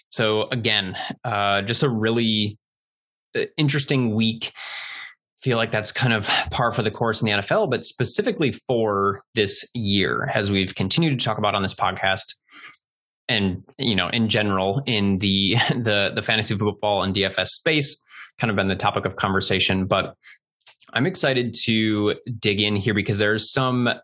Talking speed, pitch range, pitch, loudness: 165 wpm, 100-120 Hz, 110 Hz, -20 LUFS